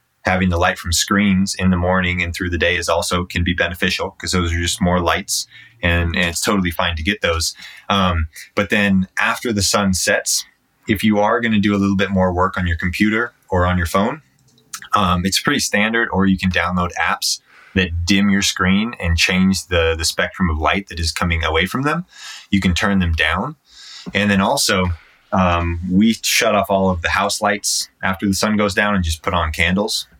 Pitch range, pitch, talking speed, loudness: 85-100 Hz, 95 Hz, 215 wpm, -17 LUFS